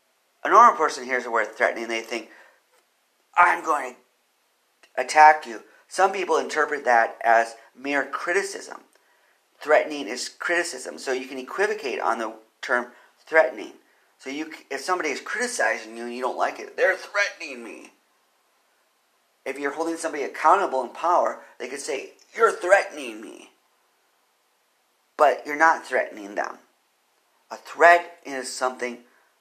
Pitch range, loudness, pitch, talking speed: 120-165 Hz, -23 LUFS, 135 Hz, 140 wpm